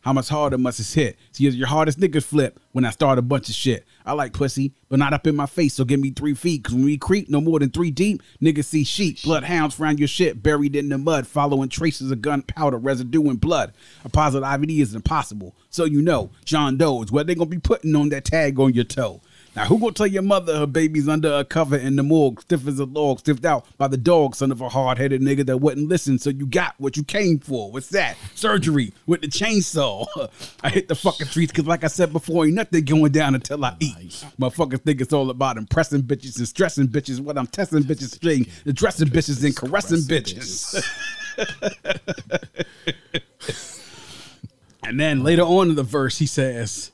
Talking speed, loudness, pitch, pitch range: 225 wpm, -21 LUFS, 145 Hz, 135-160 Hz